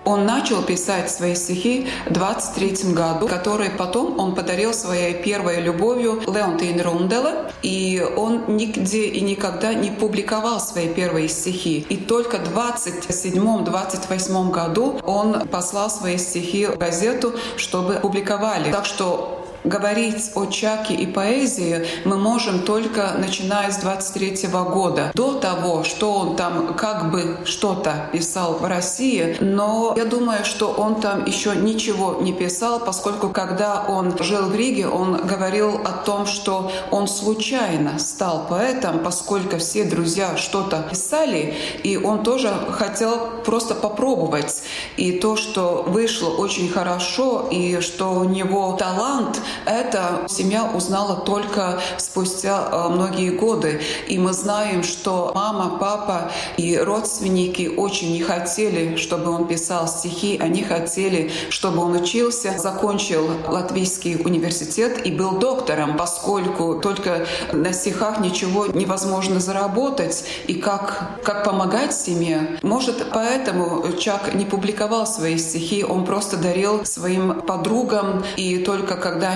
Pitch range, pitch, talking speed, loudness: 175-210 Hz, 195 Hz, 130 wpm, -21 LUFS